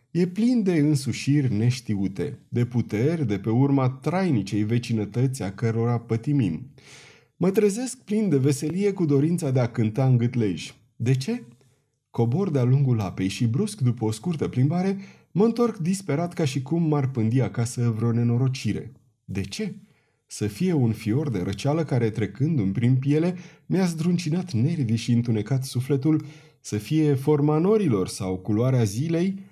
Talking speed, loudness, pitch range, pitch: 155 wpm, -24 LUFS, 115-155 Hz, 135 Hz